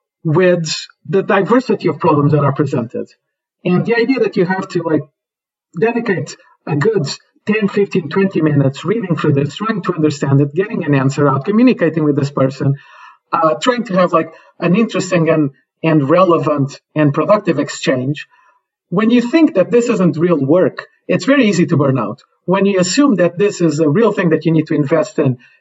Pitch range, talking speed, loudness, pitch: 150-200 Hz, 185 wpm, -15 LUFS, 170 Hz